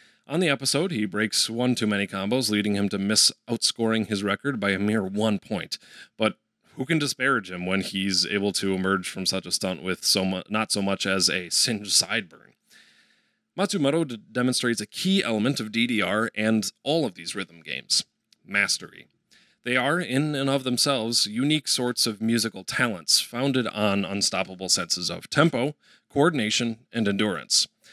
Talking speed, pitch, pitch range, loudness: 170 wpm, 110 Hz, 100-125 Hz, -24 LUFS